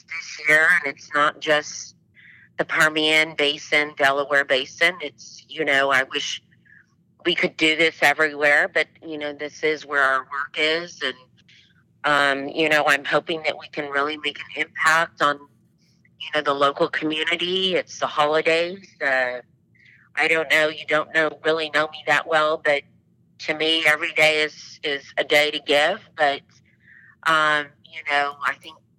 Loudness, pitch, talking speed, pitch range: -20 LUFS, 150 Hz, 170 wpm, 145-160 Hz